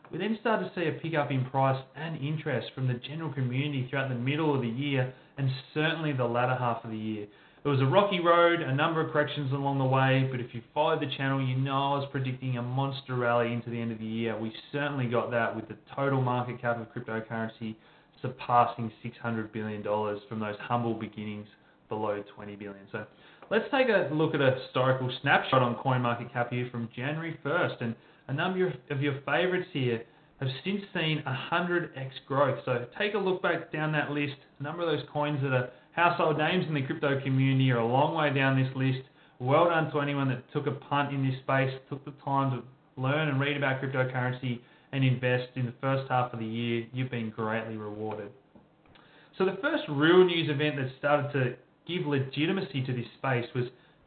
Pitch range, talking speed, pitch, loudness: 120-150 Hz, 210 wpm, 135 Hz, -29 LUFS